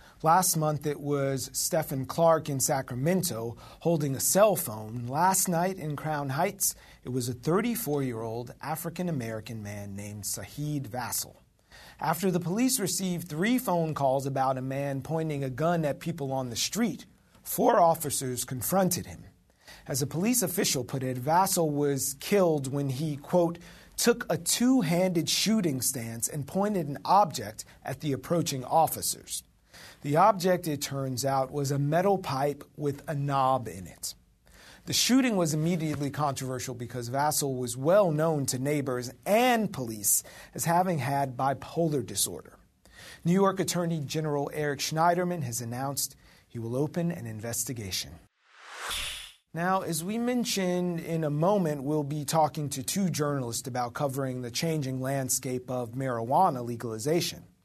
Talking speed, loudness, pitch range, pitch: 150 wpm, -28 LUFS, 130-170 Hz, 145 Hz